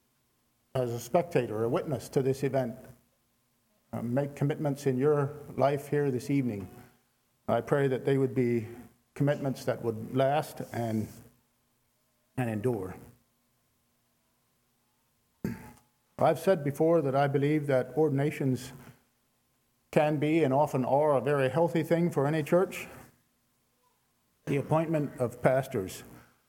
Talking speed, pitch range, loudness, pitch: 120 wpm, 120-145 Hz, -29 LUFS, 135 Hz